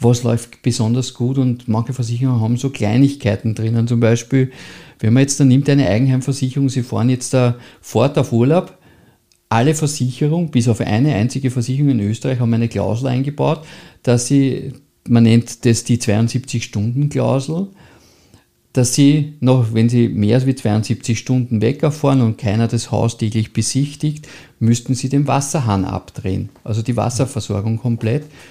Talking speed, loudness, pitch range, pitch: 150 wpm, -17 LUFS, 115-135 Hz, 125 Hz